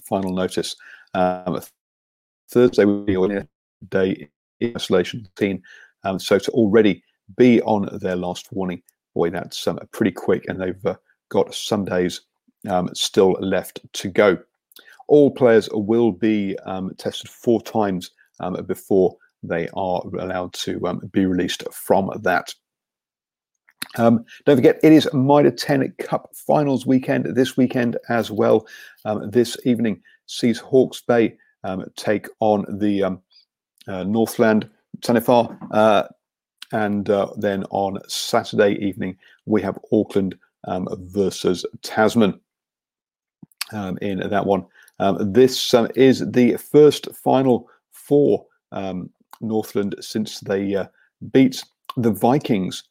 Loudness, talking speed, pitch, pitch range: -20 LUFS, 130 wpm, 105 Hz, 95-120 Hz